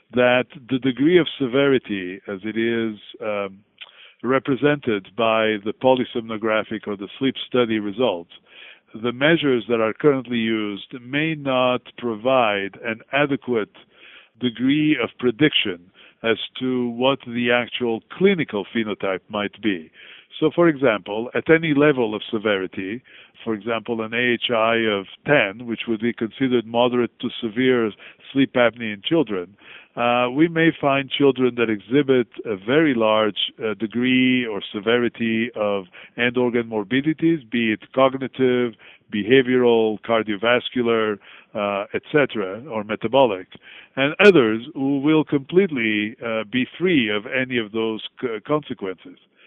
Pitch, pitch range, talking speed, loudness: 120 Hz, 110-135 Hz, 130 wpm, -21 LUFS